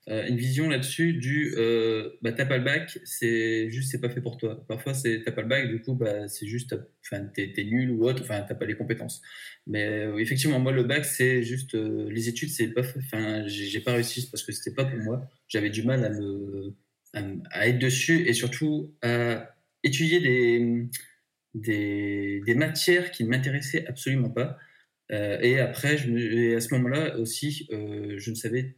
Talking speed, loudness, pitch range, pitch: 215 wpm, -27 LUFS, 110-135 Hz, 120 Hz